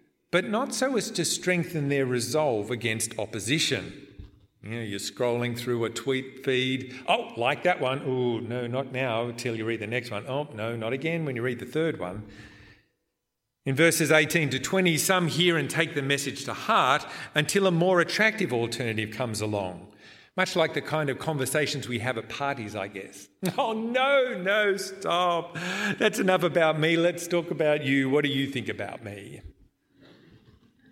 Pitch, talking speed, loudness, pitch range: 135 Hz, 180 wpm, -26 LUFS, 120-170 Hz